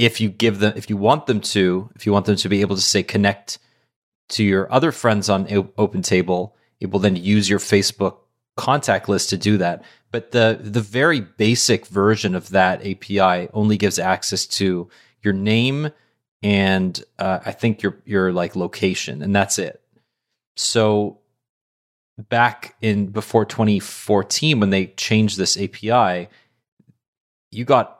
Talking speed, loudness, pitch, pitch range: 160 wpm, -19 LUFS, 105 Hz, 95-115 Hz